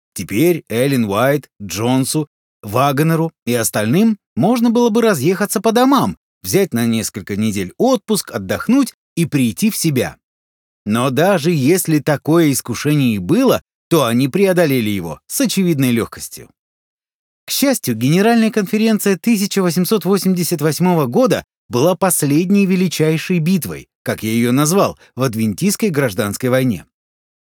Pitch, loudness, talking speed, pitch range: 160 Hz, -16 LUFS, 120 wpm, 125-200 Hz